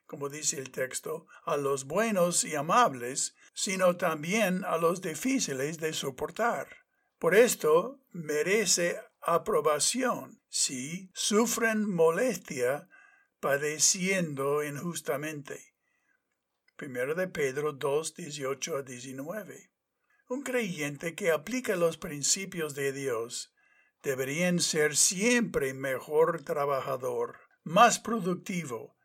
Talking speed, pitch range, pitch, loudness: 95 wpm, 150-225 Hz, 175 Hz, -29 LUFS